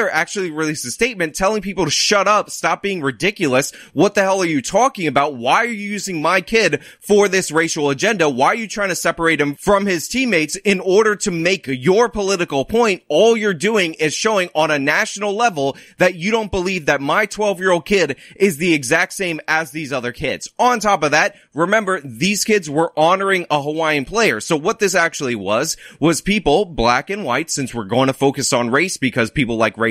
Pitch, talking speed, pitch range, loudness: 180 Hz, 215 wpm, 150-205 Hz, -17 LUFS